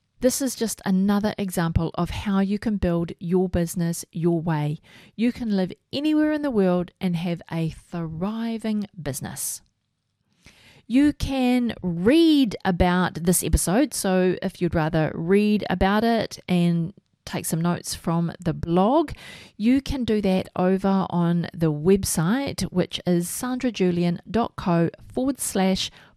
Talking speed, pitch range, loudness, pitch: 135 wpm, 175-220 Hz, -23 LUFS, 185 Hz